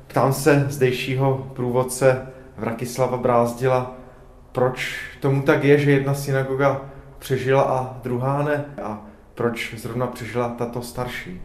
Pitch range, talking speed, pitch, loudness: 125-135 Hz, 120 wpm, 130 Hz, -22 LUFS